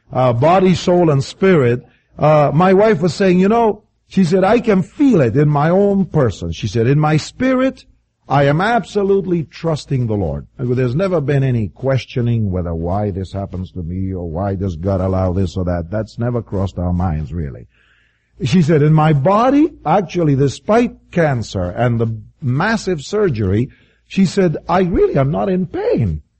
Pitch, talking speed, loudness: 140 Hz, 175 wpm, -16 LUFS